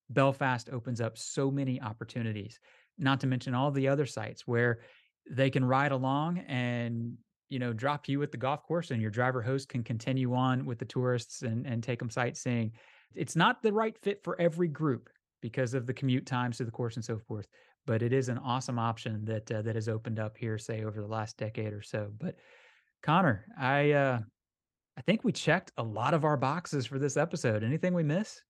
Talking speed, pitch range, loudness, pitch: 210 wpm, 115-145 Hz, -32 LUFS, 130 Hz